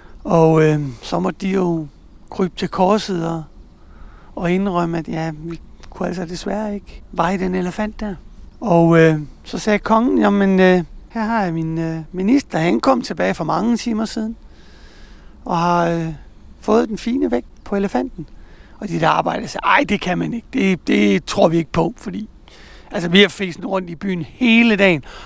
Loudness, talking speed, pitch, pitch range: -18 LUFS, 185 wpm, 180 Hz, 165-210 Hz